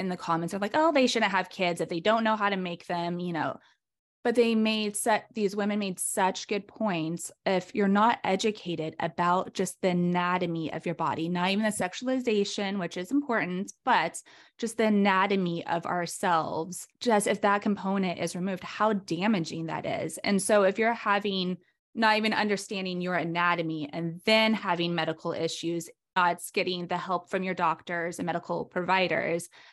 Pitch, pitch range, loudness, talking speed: 185 Hz, 175-210 Hz, -28 LUFS, 180 wpm